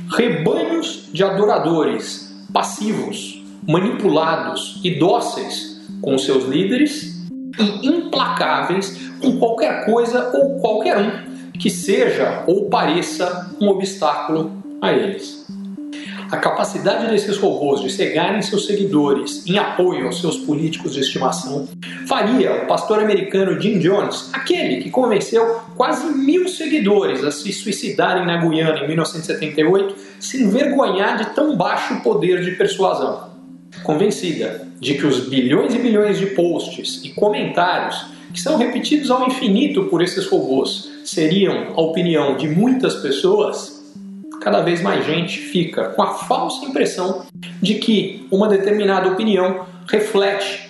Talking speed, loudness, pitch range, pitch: 130 wpm, -18 LUFS, 160-220 Hz, 195 Hz